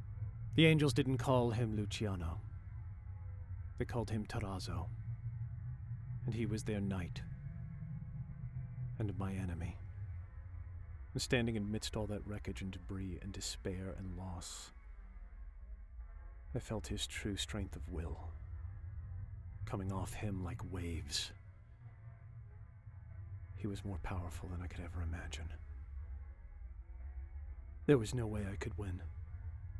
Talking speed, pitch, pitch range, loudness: 115 wpm, 95 Hz, 85-110 Hz, -41 LUFS